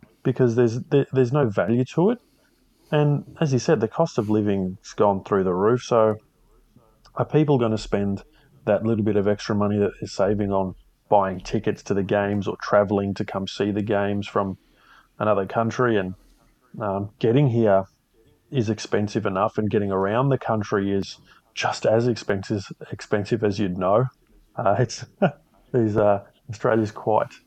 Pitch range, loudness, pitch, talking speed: 100-125 Hz, -23 LUFS, 110 Hz, 170 wpm